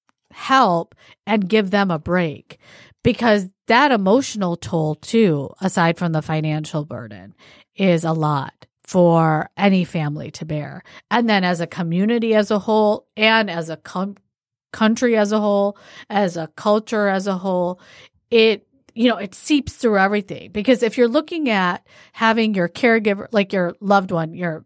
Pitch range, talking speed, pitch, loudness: 170-220 Hz, 160 wpm, 195 Hz, -19 LUFS